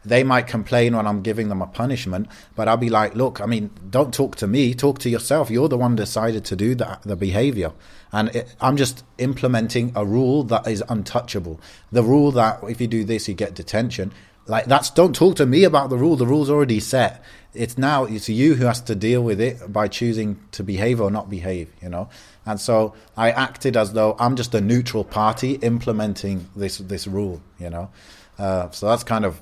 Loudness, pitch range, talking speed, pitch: -20 LUFS, 100-125 Hz, 215 wpm, 110 Hz